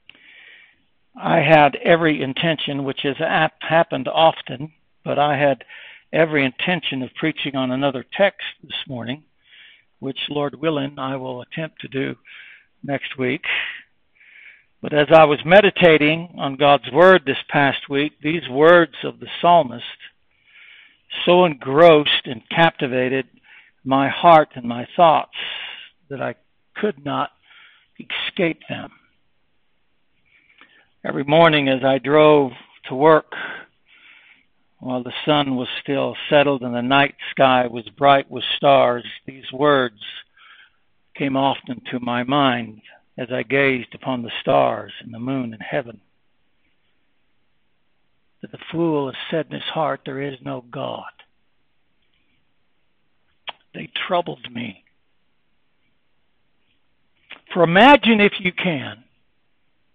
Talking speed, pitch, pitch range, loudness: 120 wpm, 140 Hz, 130-160 Hz, -18 LUFS